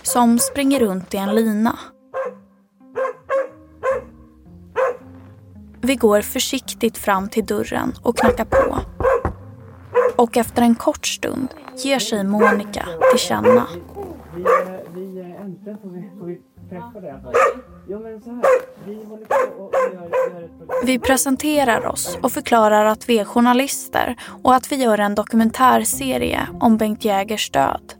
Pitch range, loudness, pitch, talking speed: 205-265 Hz, -18 LUFS, 235 Hz, 95 wpm